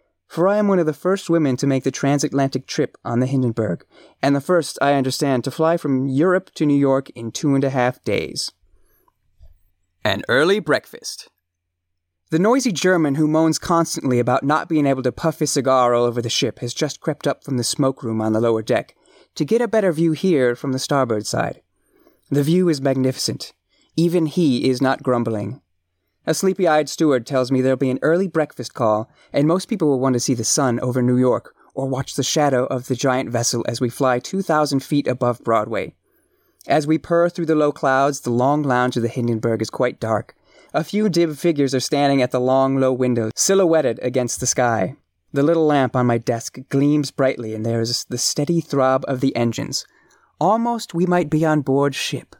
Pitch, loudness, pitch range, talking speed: 135 Hz, -19 LUFS, 125-155 Hz, 205 wpm